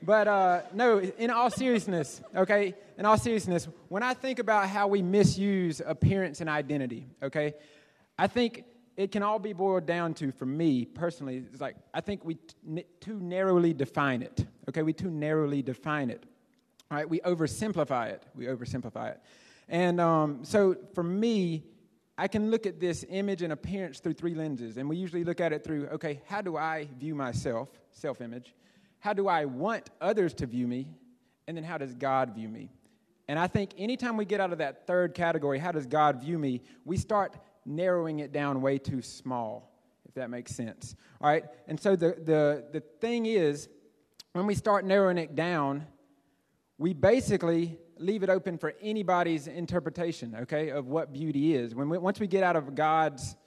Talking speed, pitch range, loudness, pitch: 190 wpm, 150-195 Hz, -30 LUFS, 165 Hz